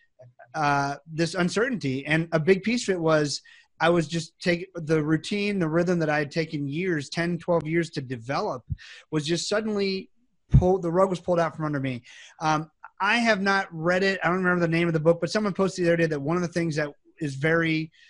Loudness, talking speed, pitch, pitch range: -25 LUFS, 225 wpm, 170 Hz, 155-180 Hz